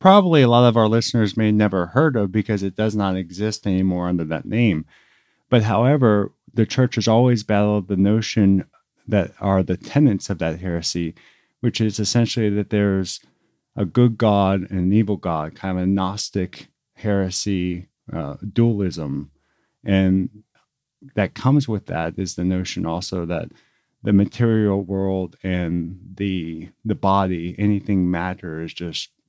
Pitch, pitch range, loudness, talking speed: 100 Hz, 90-110 Hz, -20 LUFS, 155 wpm